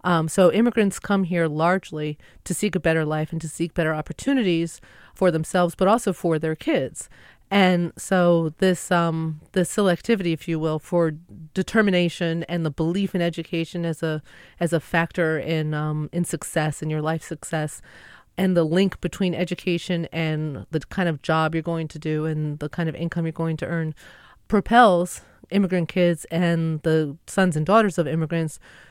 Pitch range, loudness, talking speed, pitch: 160-180 Hz, -23 LUFS, 175 wpm, 170 Hz